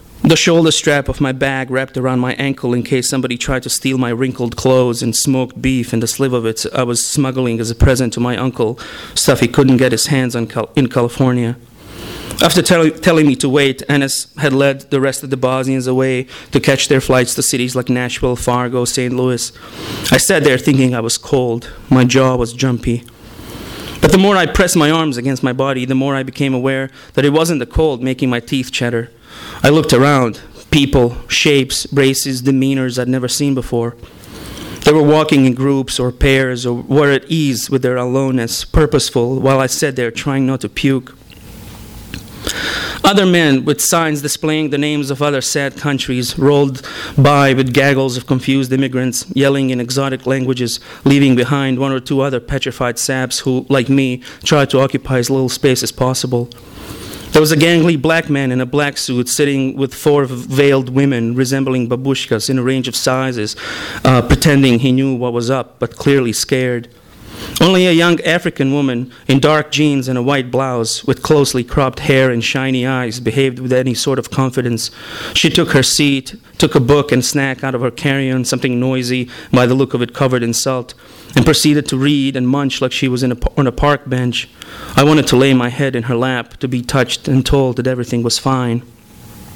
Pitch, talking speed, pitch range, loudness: 130 Hz, 200 wpm, 125-140 Hz, -14 LUFS